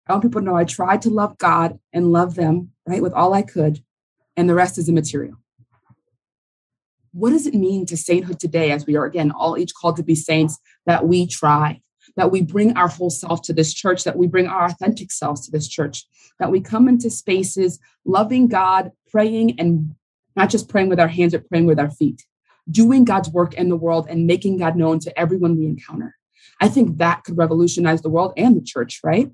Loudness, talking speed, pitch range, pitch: -18 LUFS, 215 wpm, 160-190 Hz, 175 Hz